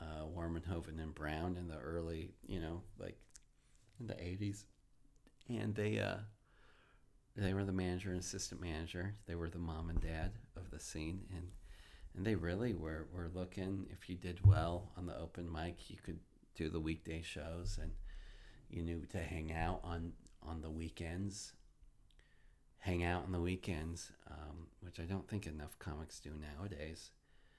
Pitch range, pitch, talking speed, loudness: 80-95 Hz, 90 Hz, 170 wpm, -43 LUFS